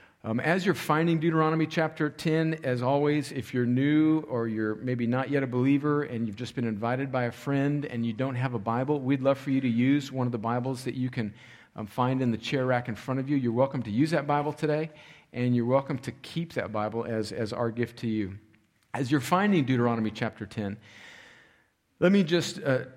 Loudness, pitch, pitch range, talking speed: -28 LUFS, 130 Hz, 115-150 Hz, 225 wpm